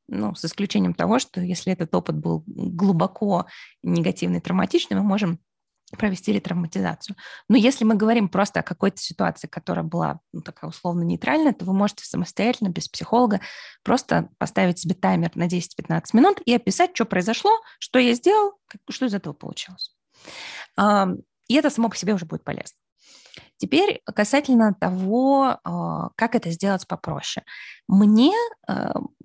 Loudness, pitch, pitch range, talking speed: -22 LUFS, 205 Hz, 180-240 Hz, 145 wpm